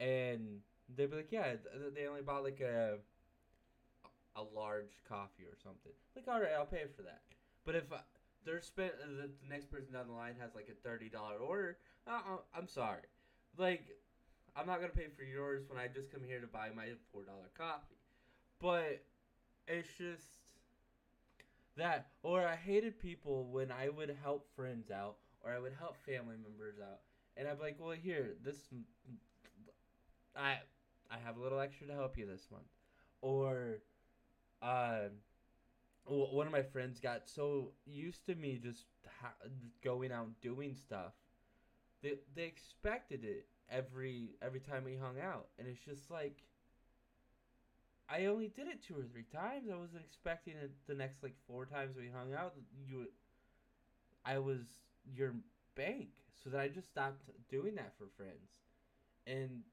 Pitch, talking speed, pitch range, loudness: 135 Hz, 165 wpm, 120-150 Hz, -45 LUFS